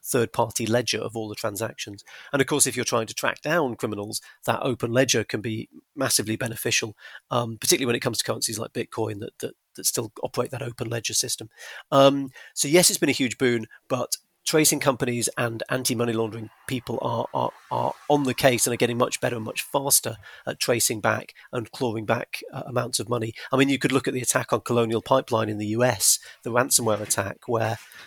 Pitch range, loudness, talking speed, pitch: 115-130 Hz, -24 LUFS, 220 wpm, 120 Hz